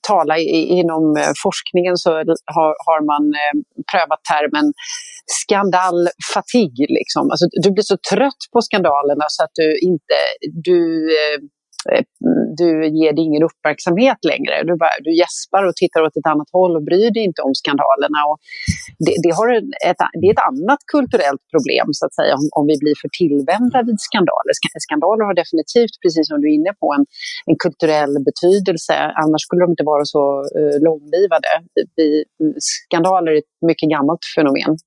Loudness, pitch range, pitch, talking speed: -16 LUFS, 155-210 Hz, 170 Hz, 155 wpm